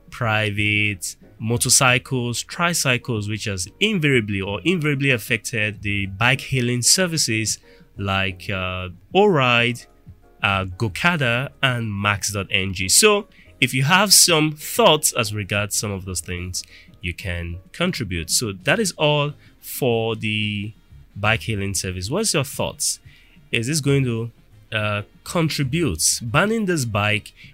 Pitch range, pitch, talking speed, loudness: 100-145 Hz, 115 Hz, 125 wpm, -20 LUFS